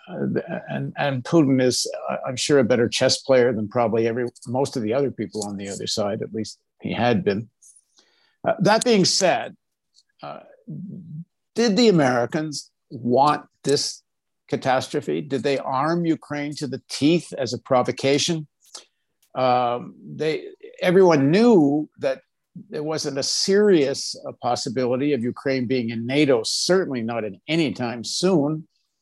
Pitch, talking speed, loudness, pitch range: 140 Hz, 145 wpm, -22 LUFS, 125-165 Hz